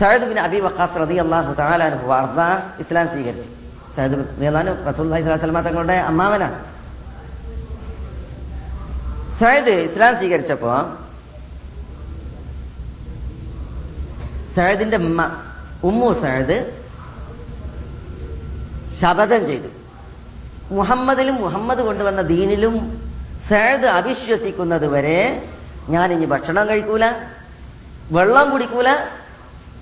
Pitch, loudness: 165 Hz, -18 LUFS